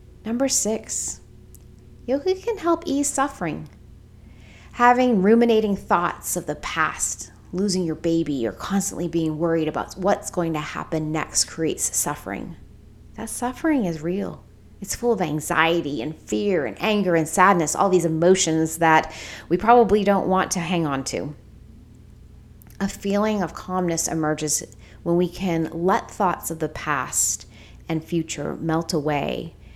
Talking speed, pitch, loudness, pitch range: 145 wpm, 165 Hz, -22 LUFS, 150-200 Hz